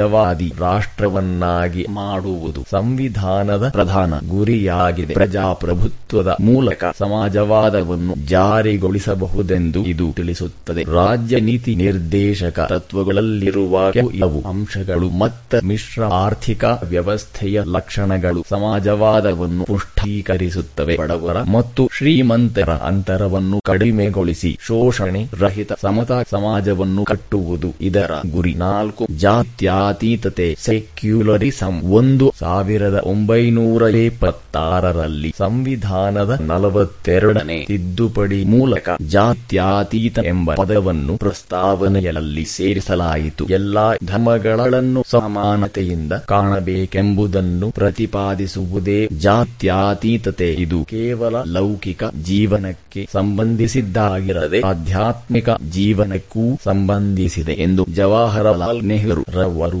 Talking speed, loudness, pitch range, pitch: 65 wpm, -17 LUFS, 90-110 Hz, 100 Hz